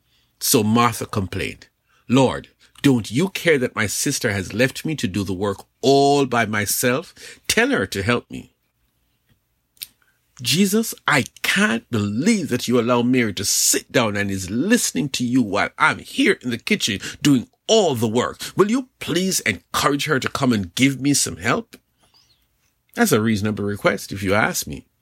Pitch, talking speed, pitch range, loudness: 125 Hz, 170 wpm, 110-145 Hz, -20 LUFS